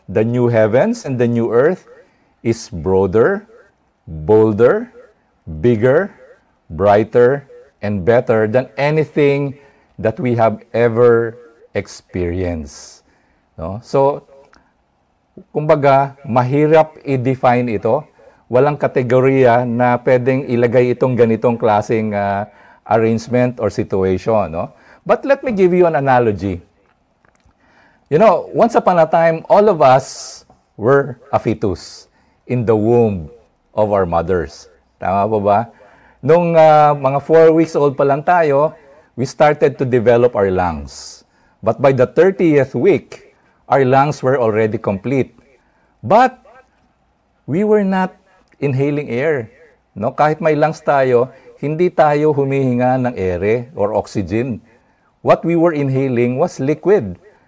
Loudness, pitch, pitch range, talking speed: -15 LUFS, 125 Hz, 110-145 Hz, 120 wpm